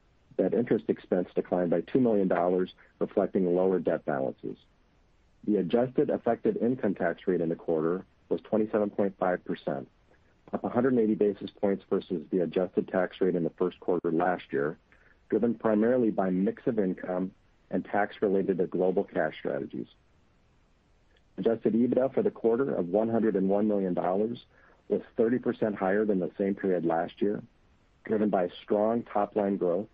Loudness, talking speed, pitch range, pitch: -29 LUFS, 145 wpm, 90-110 Hz, 100 Hz